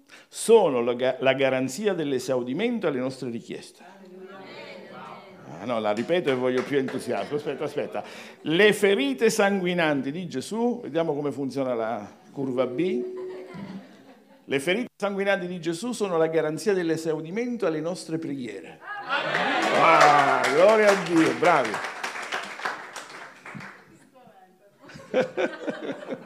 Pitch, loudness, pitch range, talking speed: 165 Hz, -24 LUFS, 135-200 Hz, 105 wpm